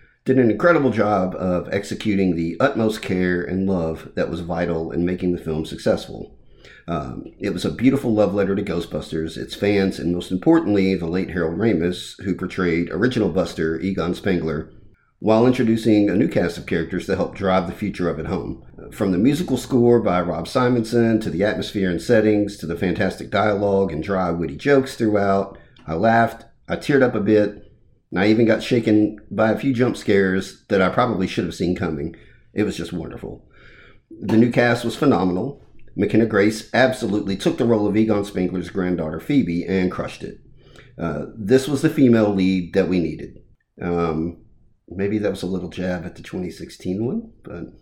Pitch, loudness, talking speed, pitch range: 100 Hz, -20 LUFS, 185 wpm, 90-115 Hz